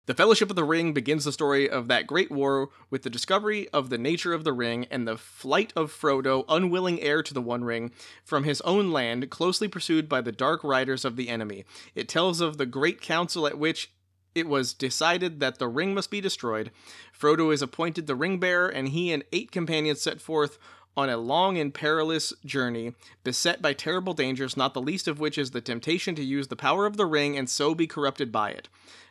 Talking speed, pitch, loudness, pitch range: 220 wpm, 145 Hz, -27 LUFS, 130-165 Hz